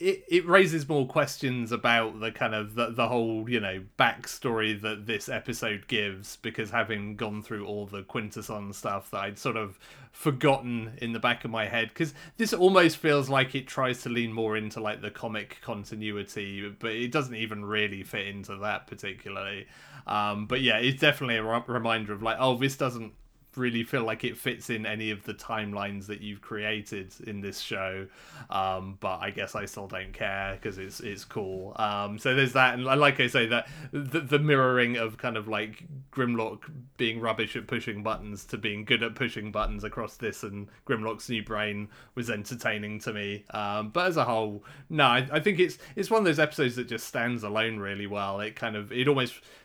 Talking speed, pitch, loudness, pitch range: 200 wpm, 115 Hz, -29 LUFS, 105-130 Hz